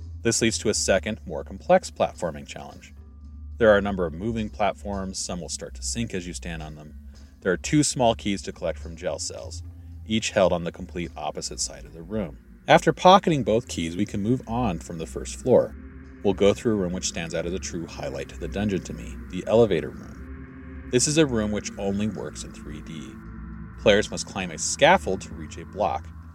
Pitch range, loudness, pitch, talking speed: 75-110 Hz, -24 LUFS, 90 Hz, 220 wpm